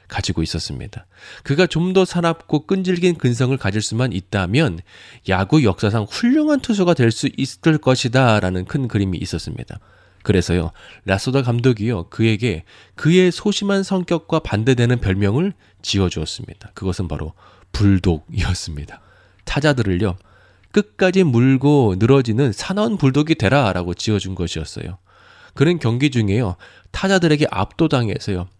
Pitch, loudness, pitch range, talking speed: 120 Hz, -18 LUFS, 95-155 Hz, 325 characters per minute